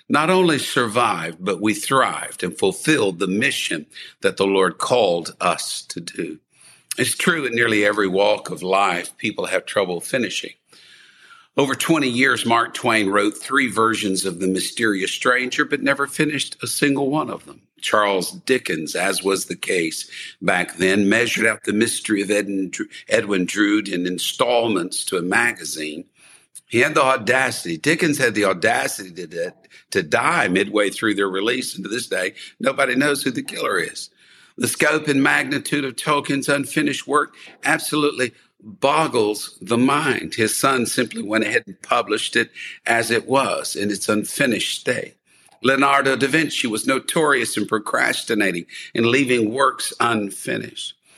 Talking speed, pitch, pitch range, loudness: 155 wpm, 120 Hz, 100-140 Hz, -20 LUFS